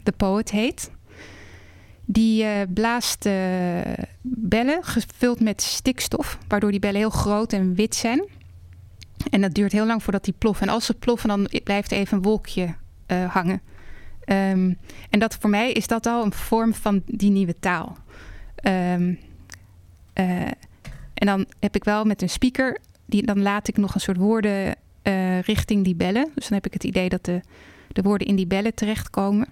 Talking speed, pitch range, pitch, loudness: 180 wpm, 185-220 Hz, 200 Hz, -23 LUFS